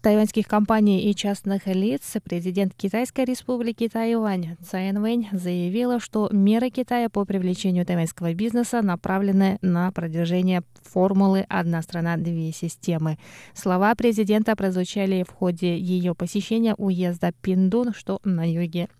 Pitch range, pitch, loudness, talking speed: 180-215 Hz, 195 Hz, -23 LUFS, 125 wpm